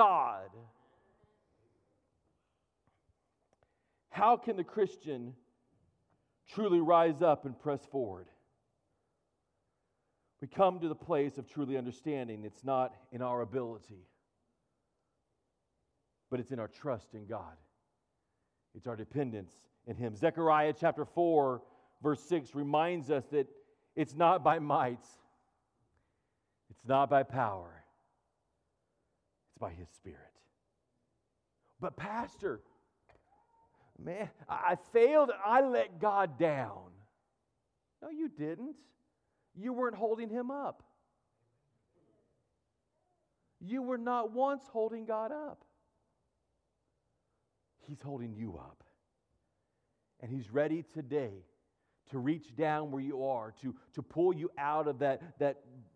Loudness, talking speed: -34 LUFS, 105 wpm